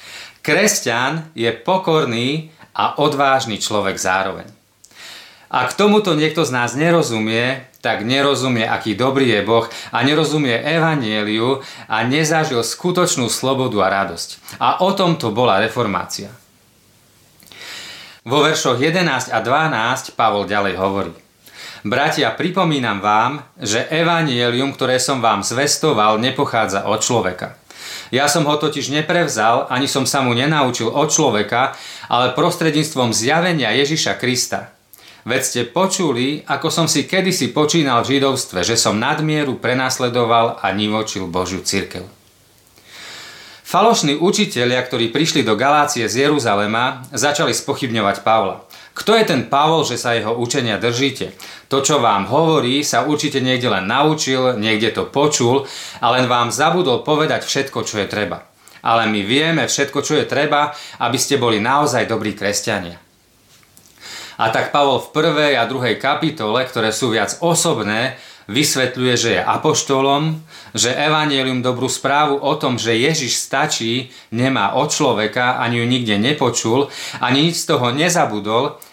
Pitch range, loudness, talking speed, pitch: 115-150 Hz, -17 LUFS, 140 wpm, 130 Hz